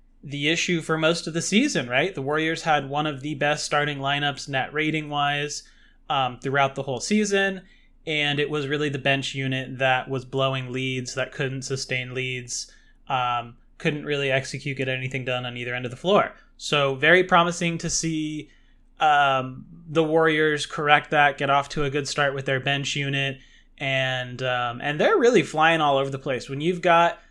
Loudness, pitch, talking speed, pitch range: -23 LUFS, 145 Hz, 190 wpm, 135-160 Hz